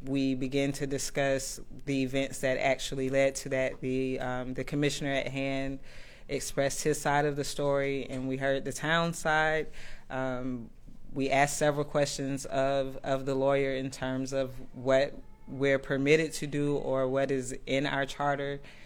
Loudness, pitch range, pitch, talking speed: -30 LUFS, 135-140 Hz, 135 Hz, 165 wpm